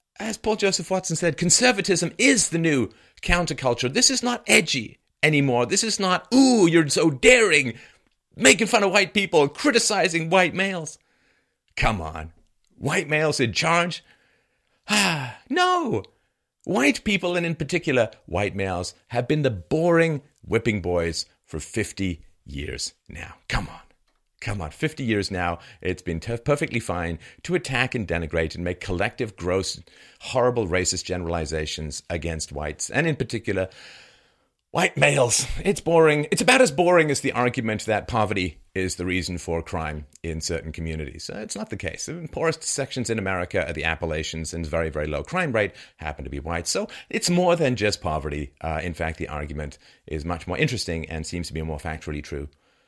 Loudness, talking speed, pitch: -23 LUFS, 170 wpm, 110 Hz